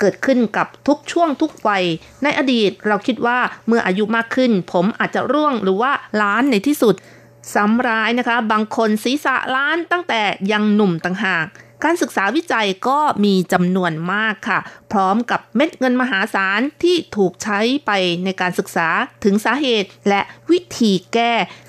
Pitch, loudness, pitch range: 220 Hz, -17 LUFS, 195-260 Hz